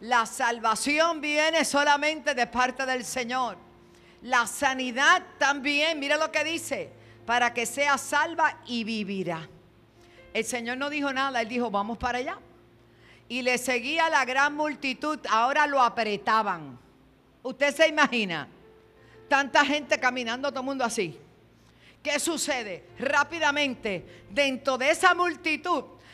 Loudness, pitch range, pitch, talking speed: -26 LUFS, 230-295 Hz, 260 Hz, 130 wpm